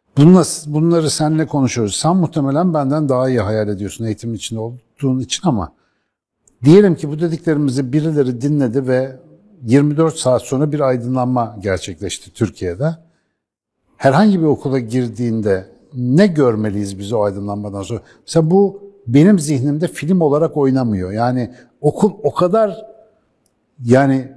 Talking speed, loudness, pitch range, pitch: 125 wpm, -16 LUFS, 115-160 Hz, 135 Hz